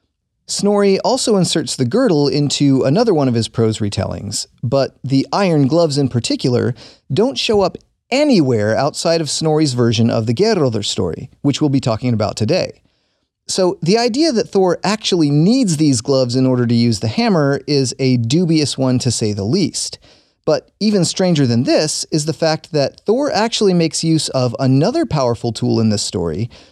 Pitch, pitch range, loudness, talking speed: 140 Hz, 120-175 Hz, -16 LUFS, 175 wpm